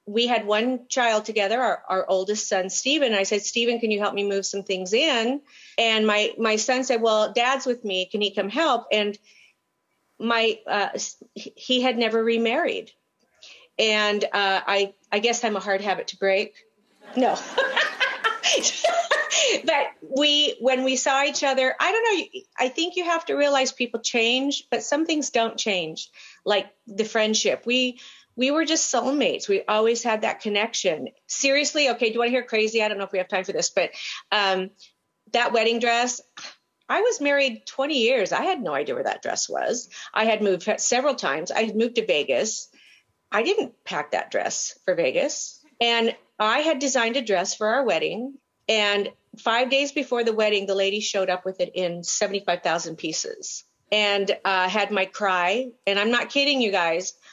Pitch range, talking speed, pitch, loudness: 205-275 Hz, 185 wpm, 230 Hz, -23 LUFS